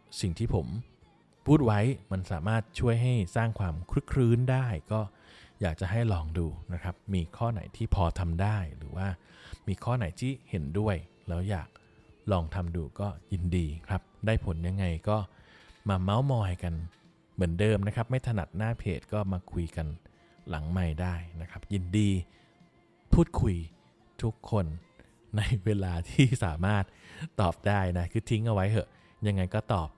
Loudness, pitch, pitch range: -31 LUFS, 100 Hz, 90-110 Hz